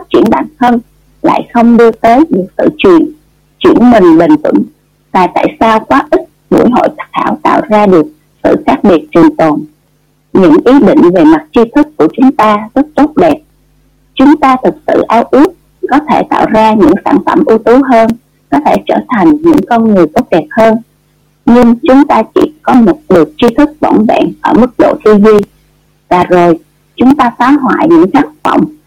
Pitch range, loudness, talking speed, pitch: 195-300 Hz, -7 LUFS, 195 wpm, 240 Hz